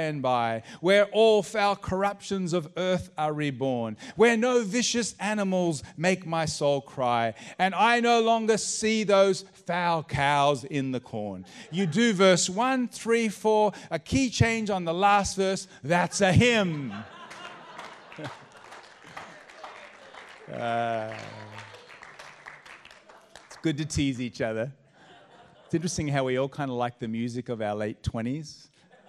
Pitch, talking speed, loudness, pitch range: 170 Hz, 135 wpm, -26 LUFS, 130-200 Hz